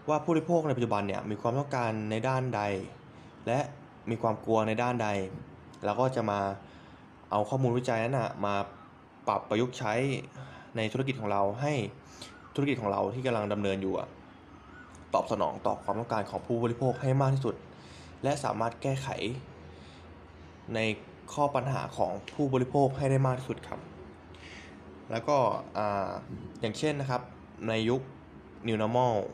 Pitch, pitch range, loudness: 115 Hz, 100-130 Hz, -31 LUFS